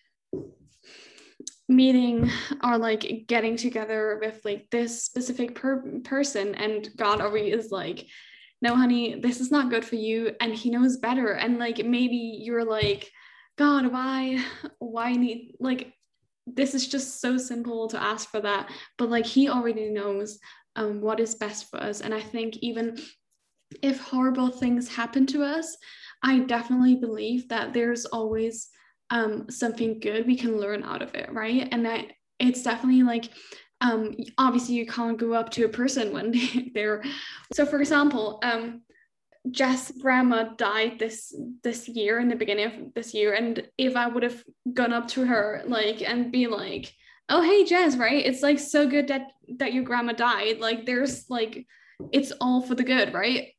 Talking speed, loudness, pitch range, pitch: 170 wpm, -26 LUFS, 225-255 Hz, 240 Hz